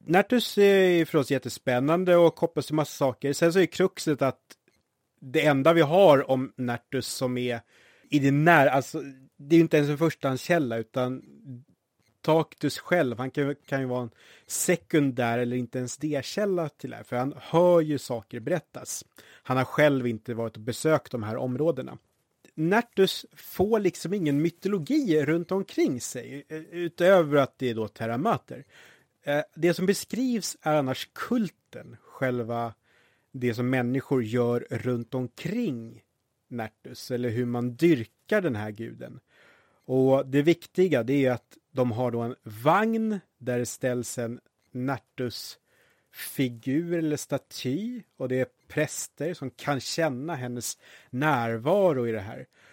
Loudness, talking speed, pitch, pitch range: -26 LUFS, 150 wpm, 135 Hz, 125-165 Hz